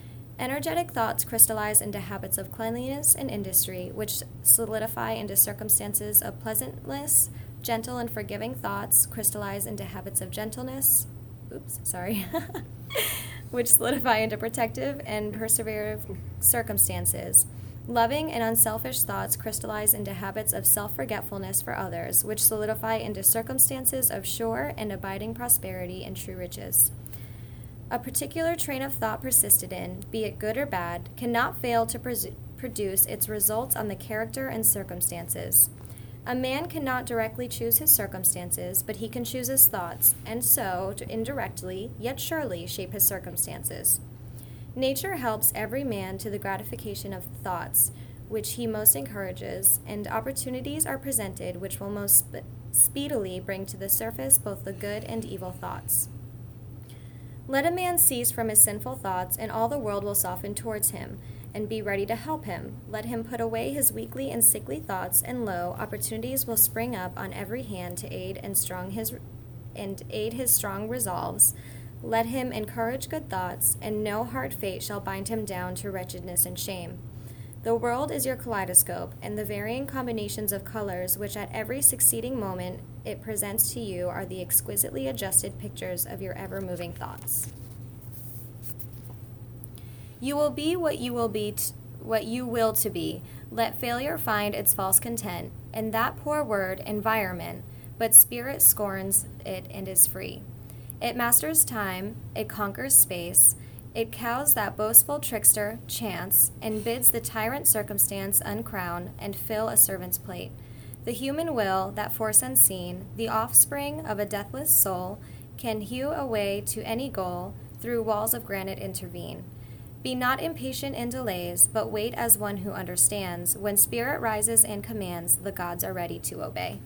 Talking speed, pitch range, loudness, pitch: 155 wpm, 110-140 Hz, -24 LUFS, 120 Hz